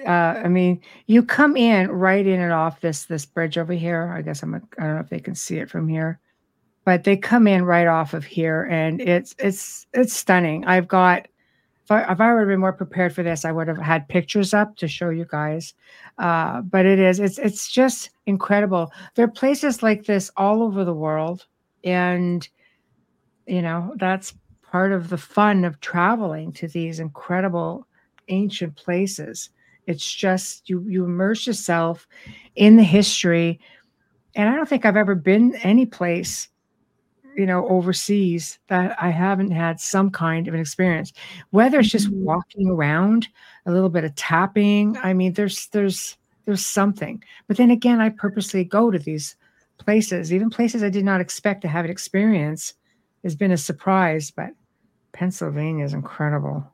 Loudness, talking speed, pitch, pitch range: -20 LUFS, 180 wpm, 185 Hz, 170-205 Hz